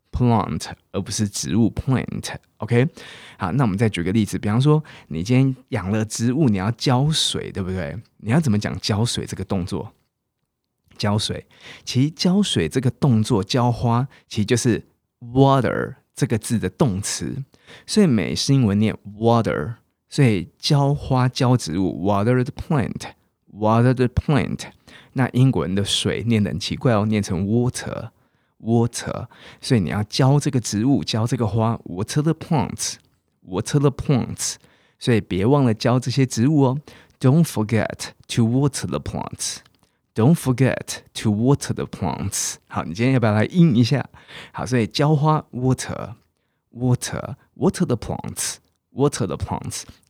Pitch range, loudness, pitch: 105-135 Hz, -21 LUFS, 120 Hz